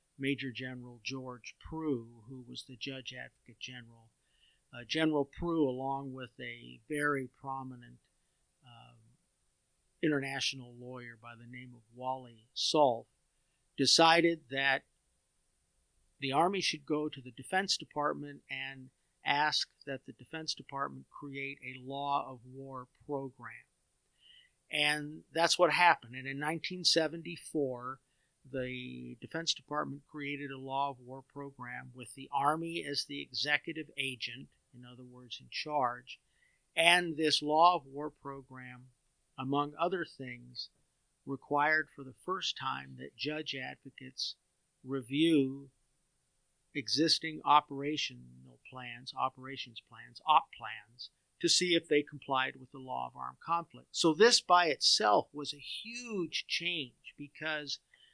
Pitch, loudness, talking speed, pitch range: 135 Hz, -33 LUFS, 125 wpm, 125-150 Hz